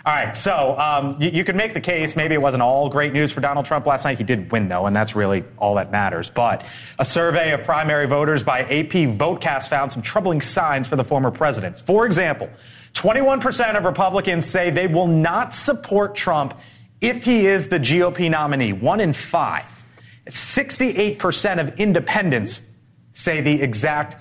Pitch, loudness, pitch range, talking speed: 150 Hz, -19 LUFS, 135-180 Hz, 185 wpm